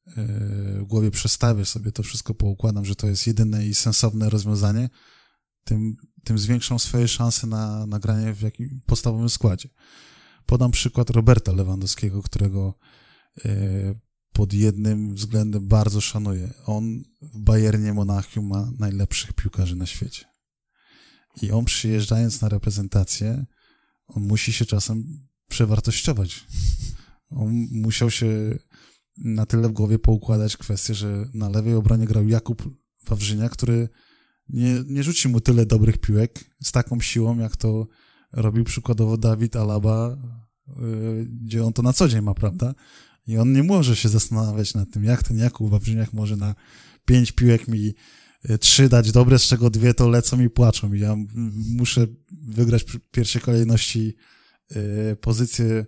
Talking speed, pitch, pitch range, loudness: 140 wpm, 110 Hz, 105-120 Hz, -21 LUFS